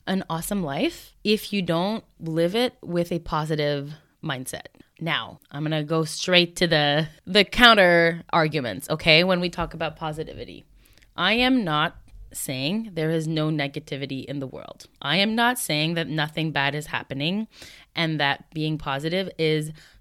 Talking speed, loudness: 160 wpm, -23 LUFS